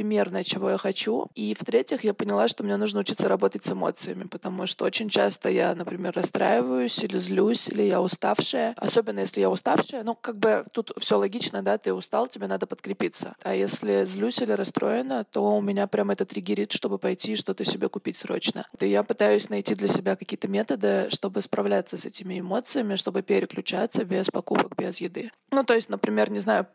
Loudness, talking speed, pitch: -25 LUFS, 195 wpm, 195 Hz